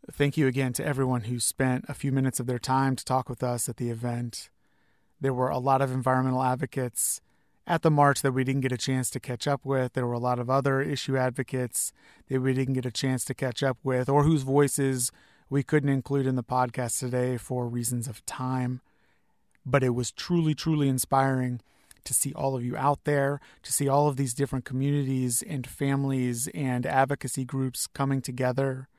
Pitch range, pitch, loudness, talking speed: 125-140 Hz, 130 Hz, -27 LUFS, 205 wpm